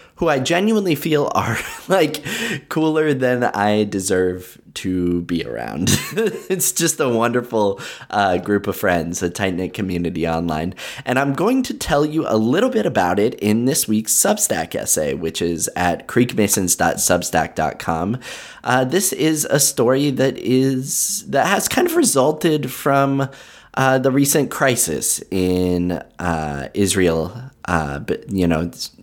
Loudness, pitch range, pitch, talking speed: -18 LUFS, 90-145 Hz, 120 Hz, 145 wpm